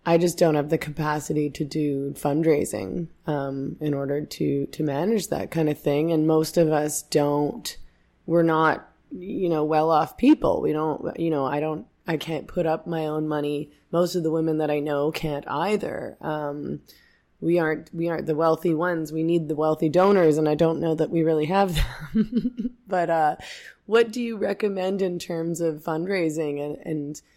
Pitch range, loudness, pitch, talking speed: 150-170 Hz, -24 LUFS, 160 Hz, 190 wpm